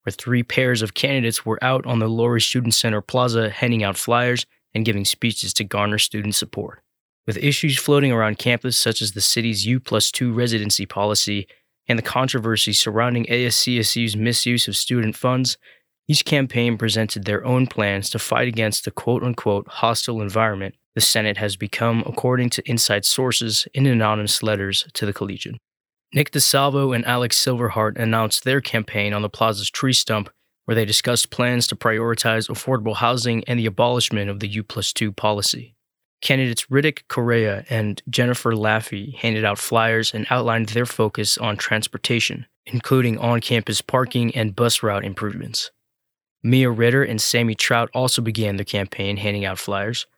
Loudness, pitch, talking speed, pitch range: -20 LUFS, 115 Hz, 165 wpm, 105-125 Hz